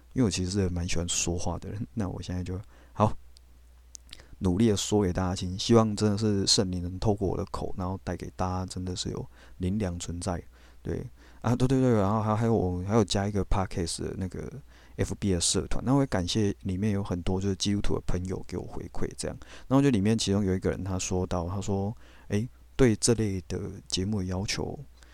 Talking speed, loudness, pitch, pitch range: 320 characters per minute, -29 LUFS, 95 Hz, 90-105 Hz